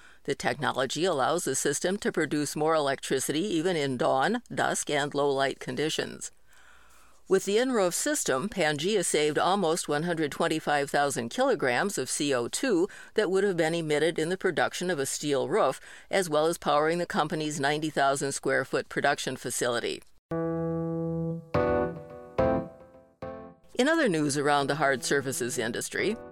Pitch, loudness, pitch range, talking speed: 160 Hz, -28 LUFS, 140-180 Hz, 135 wpm